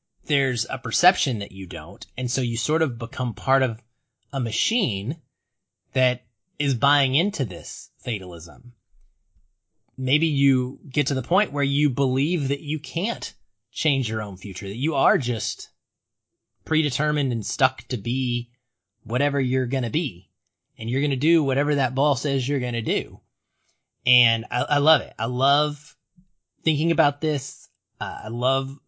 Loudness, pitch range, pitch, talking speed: -23 LUFS, 115-145 Hz, 130 Hz, 155 wpm